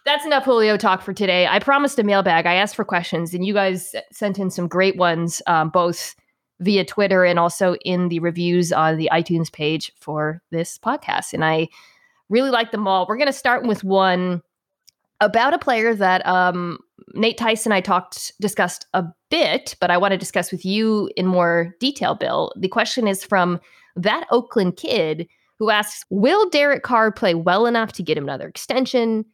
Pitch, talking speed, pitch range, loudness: 190 Hz, 190 wpm, 175-225 Hz, -19 LUFS